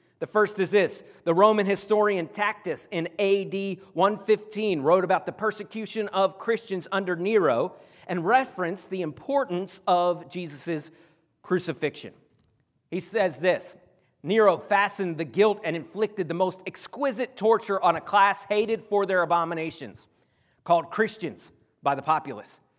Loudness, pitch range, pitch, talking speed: -25 LUFS, 170-210 Hz, 190 Hz, 135 wpm